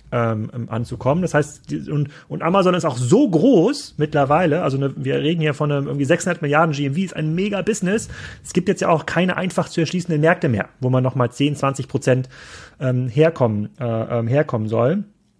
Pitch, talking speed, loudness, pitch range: 150 Hz, 185 wpm, -20 LUFS, 130-170 Hz